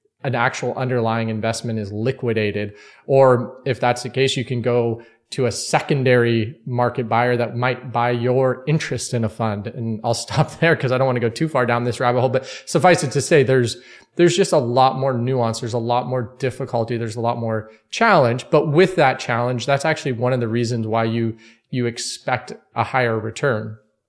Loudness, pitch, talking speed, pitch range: -20 LUFS, 120 Hz, 205 wpm, 115-130 Hz